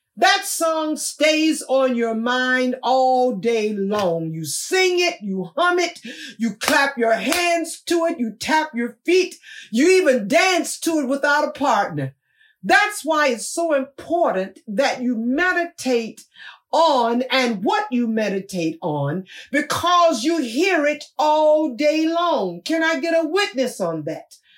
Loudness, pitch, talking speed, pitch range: -19 LUFS, 285 Hz, 150 wpm, 230-330 Hz